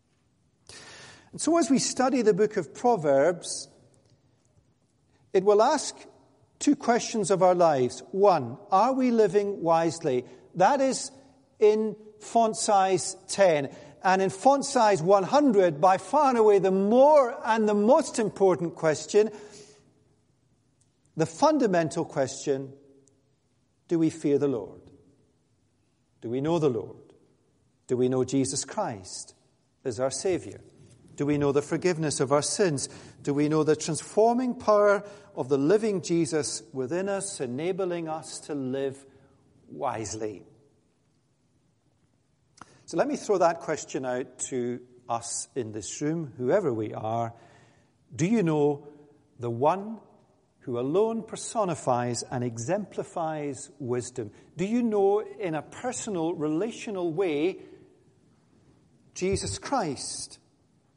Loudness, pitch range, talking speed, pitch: -26 LUFS, 135-210 Hz, 125 wpm, 160 Hz